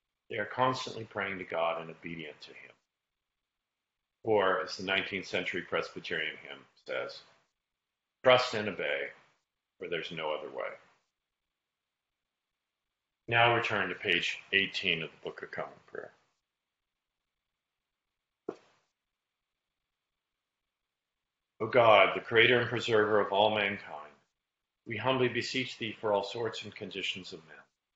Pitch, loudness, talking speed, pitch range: 105 Hz, -30 LUFS, 125 wpm, 95-115 Hz